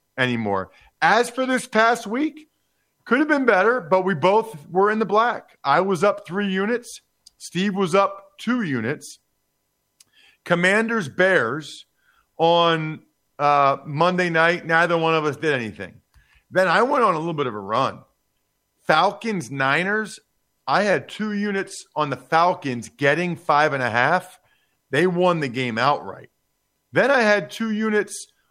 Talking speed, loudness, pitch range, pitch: 155 wpm, -21 LUFS, 150-215 Hz, 180 Hz